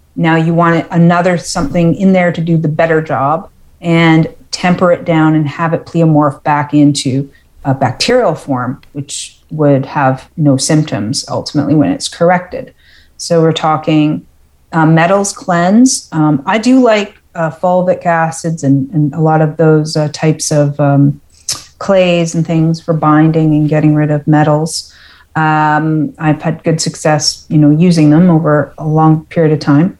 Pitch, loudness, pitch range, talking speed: 155 Hz, -11 LUFS, 150-170 Hz, 165 wpm